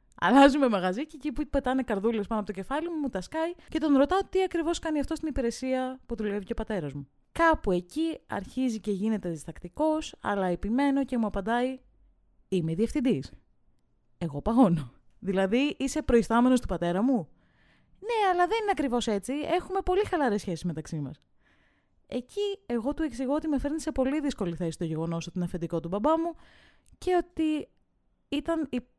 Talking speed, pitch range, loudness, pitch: 180 wpm, 195-310 Hz, -28 LUFS, 255 Hz